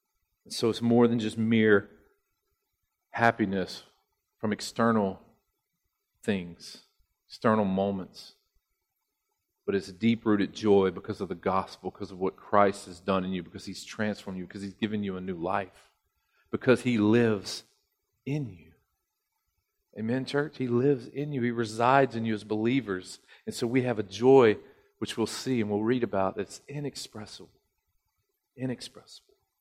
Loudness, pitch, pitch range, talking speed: -28 LUFS, 110 Hz, 100-125 Hz, 150 wpm